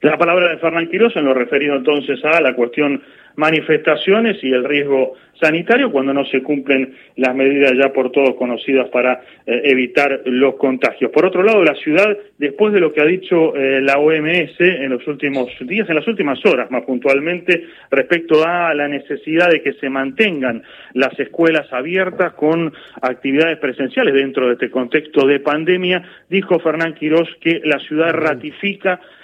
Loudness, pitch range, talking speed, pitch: -16 LUFS, 135-170 Hz, 170 wpm, 150 Hz